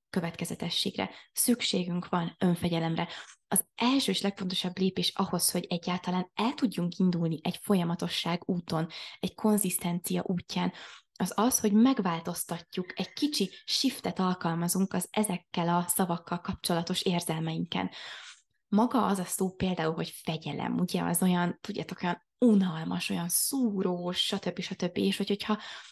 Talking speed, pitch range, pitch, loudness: 125 wpm, 175-200 Hz, 185 Hz, -30 LUFS